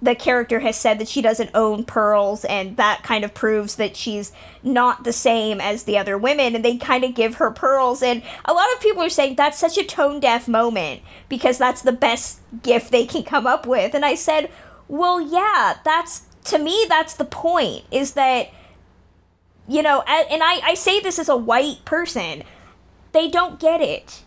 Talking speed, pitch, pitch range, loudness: 205 wpm, 255 Hz, 225-315 Hz, -19 LUFS